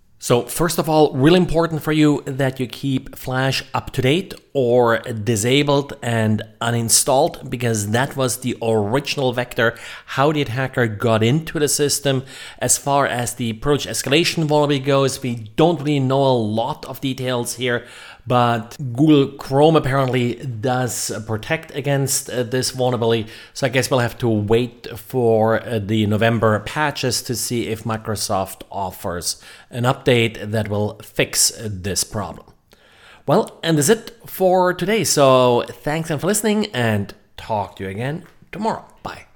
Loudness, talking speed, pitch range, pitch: -19 LUFS, 150 wpm, 115-145 Hz, 130 Hz